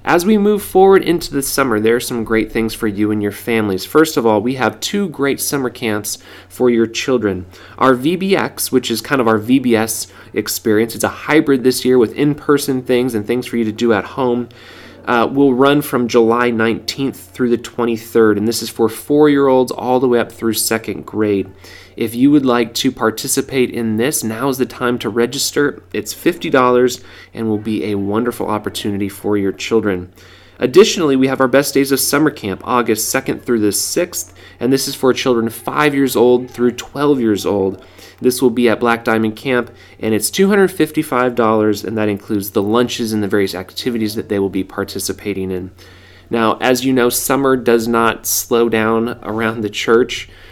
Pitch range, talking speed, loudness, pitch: 105-130 Hz, 195 wpm, -15 LUFS, 115 Hz